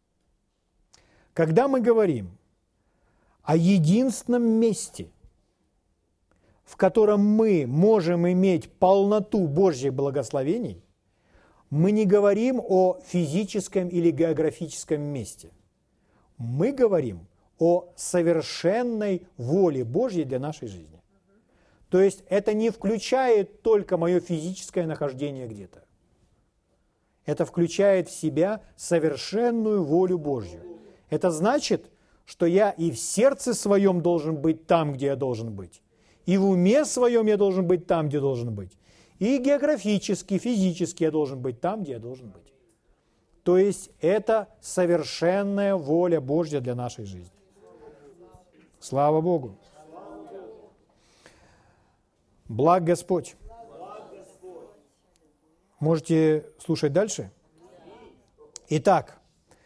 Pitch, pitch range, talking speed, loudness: 175 Hz, 140-200 Hz, 105 wpm, -24 LUFS